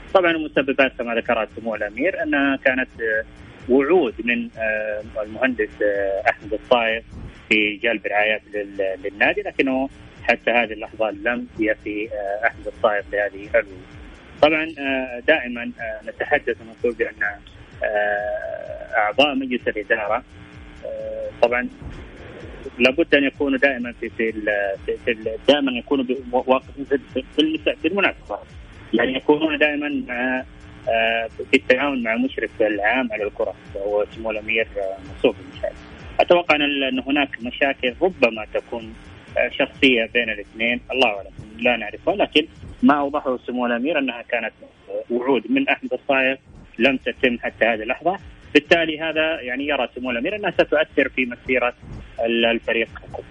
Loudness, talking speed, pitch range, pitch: -21 LUFS, 110 wpm, 110-150 Hz, 125 Hz